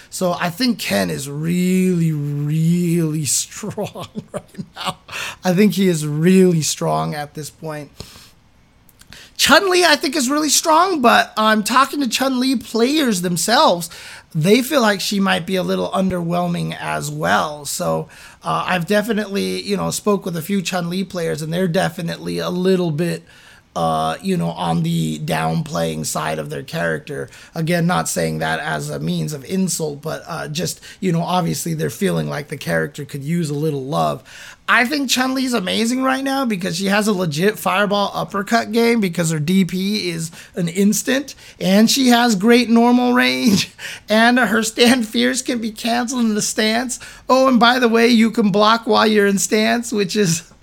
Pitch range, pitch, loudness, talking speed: 160-230 Hz, 190 Hz, -17 LUFS, 180 wpm